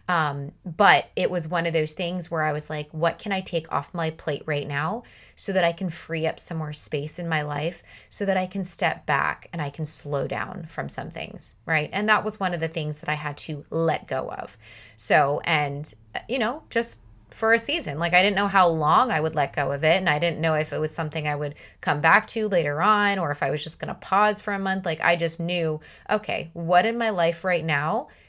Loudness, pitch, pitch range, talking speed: -24 LUFS, 165 Hz, 155-190 Hz, 250 wpm